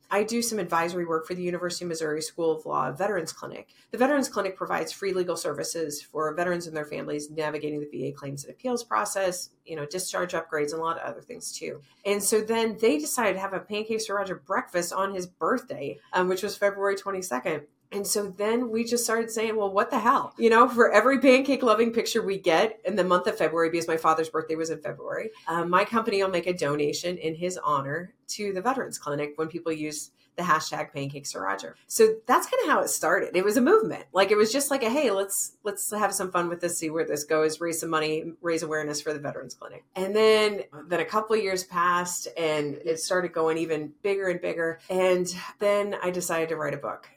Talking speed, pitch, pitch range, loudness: 230 wpm, 180 Hz, 160-215 Hz, -26 LUFS